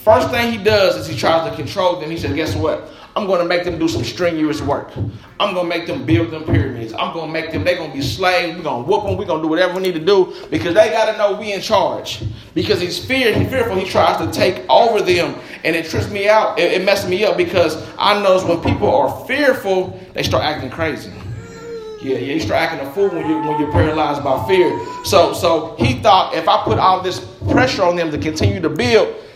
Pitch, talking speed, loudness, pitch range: 175 Hz, 255 wpm, -17 LUFS, 150-200 Hz